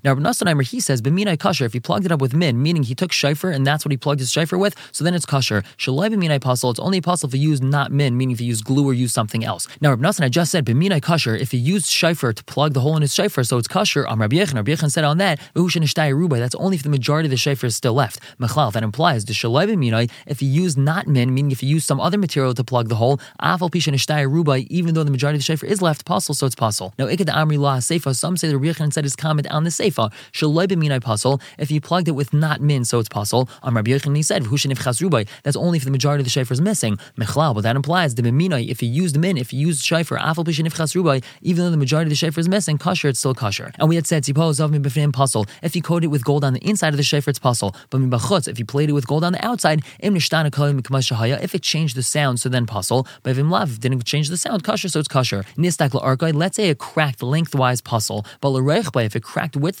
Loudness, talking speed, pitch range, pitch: -19 LUFS, 240 wpm, 130-165 Hz, 145 Hz